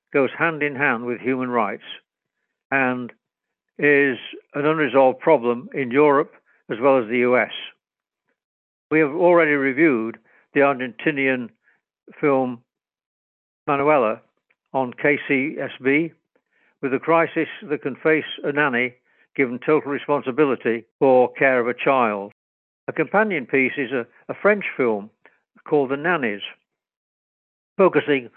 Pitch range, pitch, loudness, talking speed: 125-150 Hz, 135 Hz, -20 LUFS, 120 wpm